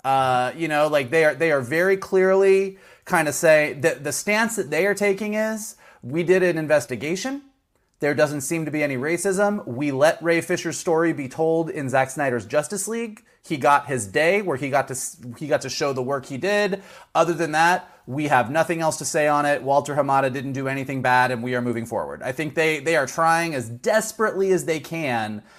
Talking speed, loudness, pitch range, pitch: 215 wpm, -22 LUFS, 135-180 Hz, 155 Hz